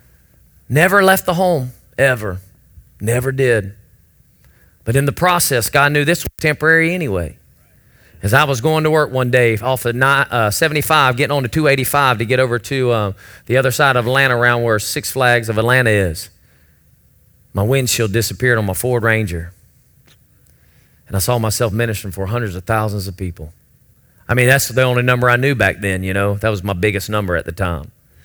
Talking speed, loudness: 185 wpm, -15 LUFS